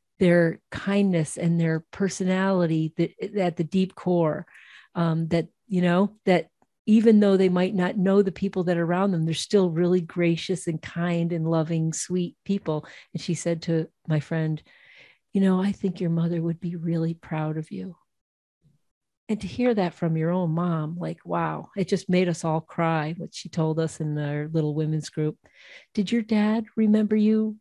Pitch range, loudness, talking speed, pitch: 165-195 Hz, -25 LUFS, 185 wpm, 175 Hz